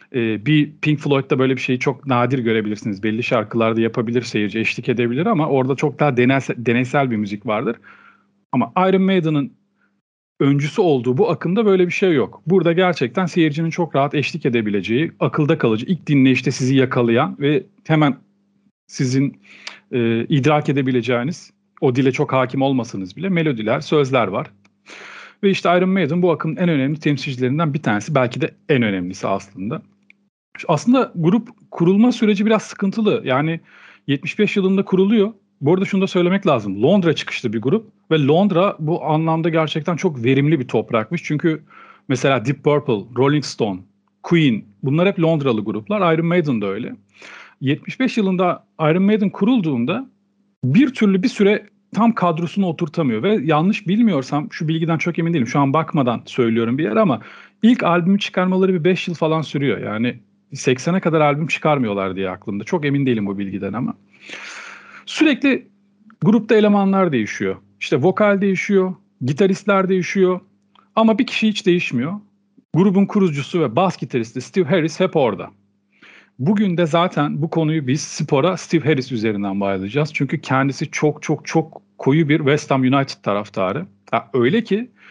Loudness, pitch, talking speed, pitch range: -18 LUFS, 160 Hz, 155 wpm, 130-190 Hz